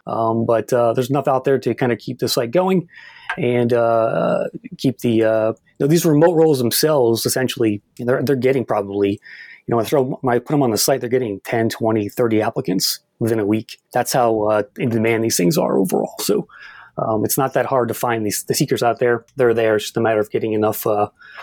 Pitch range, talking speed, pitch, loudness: 110-130 Hz, 230 wpm, 115 Hz, -18 LUFS